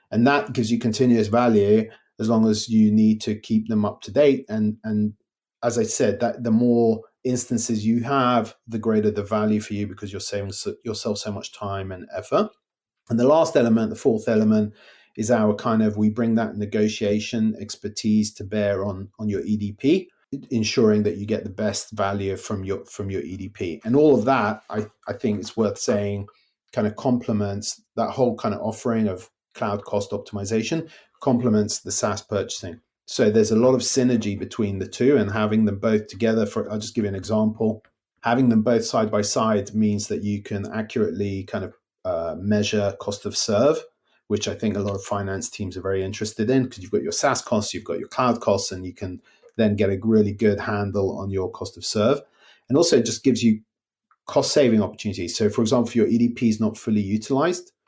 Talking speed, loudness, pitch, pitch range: 205 wpm, -23 LUFS, 110 Hz, 105-115 Hz